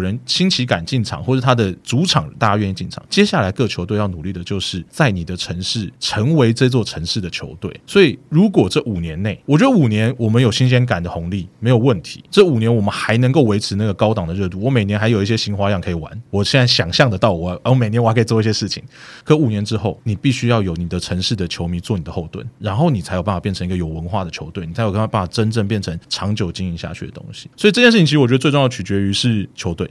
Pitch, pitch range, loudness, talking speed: 110 Hz, 95-125 Hz, -17 LUFS, 395 characters per minute